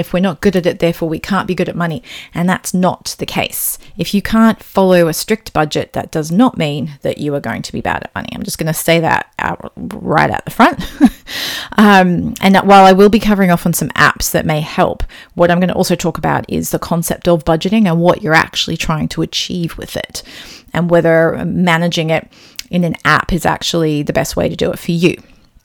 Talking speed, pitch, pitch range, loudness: 240 wpm, 175 Hz, 165-190 Hz, -14 LUFS